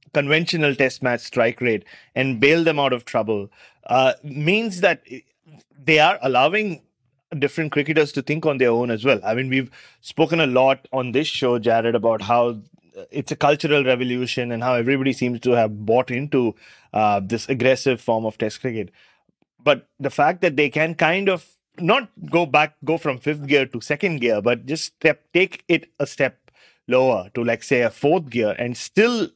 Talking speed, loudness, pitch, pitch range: 185 wpm, -20 LUFS, 135 Hz, 120-155 Hz